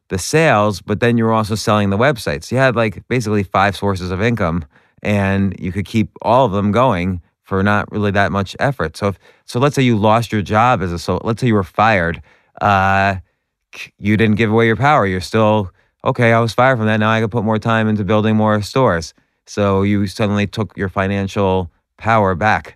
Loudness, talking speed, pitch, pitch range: -16 LUFS, 220 wpm, 105 Hz, 95-115 Hz